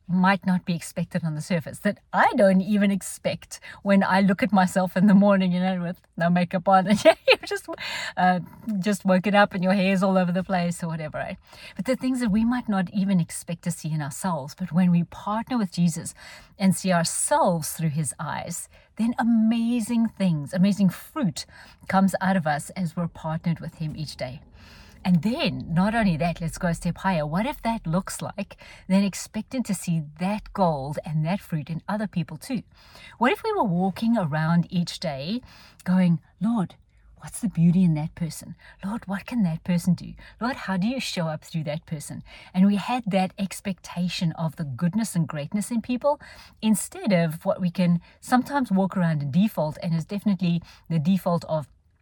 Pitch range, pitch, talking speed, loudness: 170-205 Hz, 185 Hz, 200 wpm, -24 LUFS